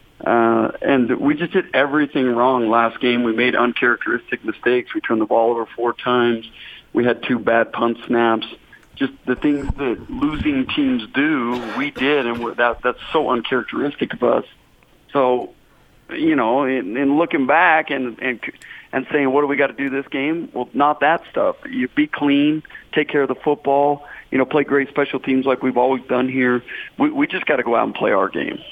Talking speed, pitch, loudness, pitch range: 200 wpm, 135 Hz, -19 LUFS, 125-155 Hz